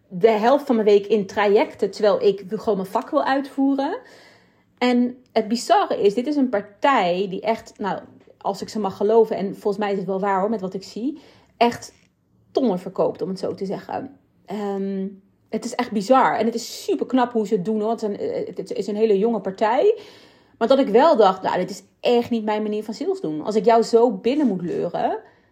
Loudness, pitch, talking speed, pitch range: -21 LUFS, 225 Hz, 225 wpm, 205-250 Hz